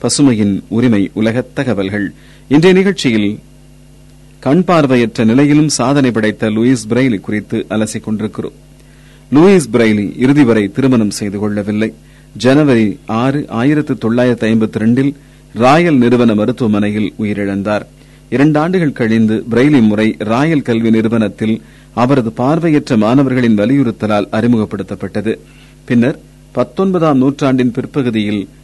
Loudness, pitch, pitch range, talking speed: -12 LUFS, 115 Hz, 110-135 Hz, 90 wpm